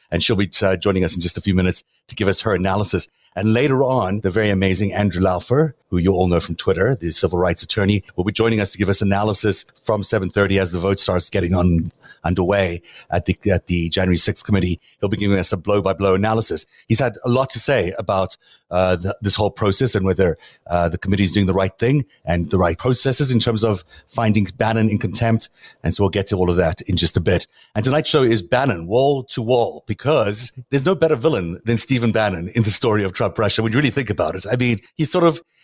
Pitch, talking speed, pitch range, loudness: 100 Hz, 245 wpm, 95-115 Hz, -19 LUFS